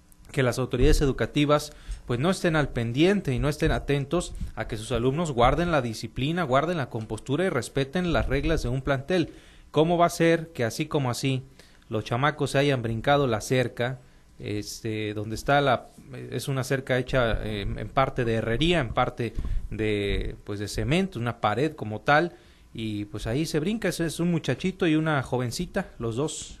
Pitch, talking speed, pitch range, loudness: 135 Hz, 185 wpm, 115-155 Hz, -26 LUFS